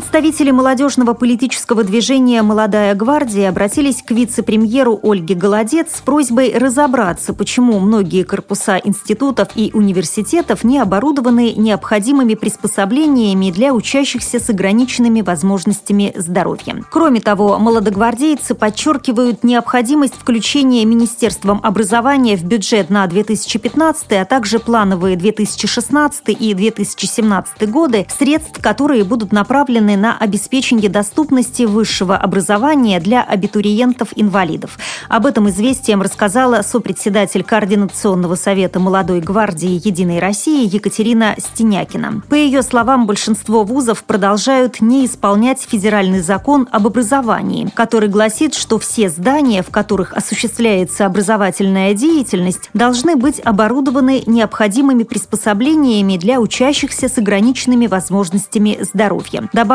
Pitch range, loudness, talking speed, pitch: 205-250 Hz, -13 LUFS, 105 wpm, 220 Hz